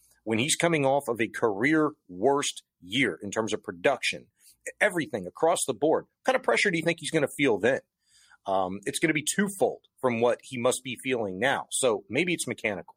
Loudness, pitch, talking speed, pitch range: -27 LUFS, 130 Hz, 215 wpm, 110-155 Hz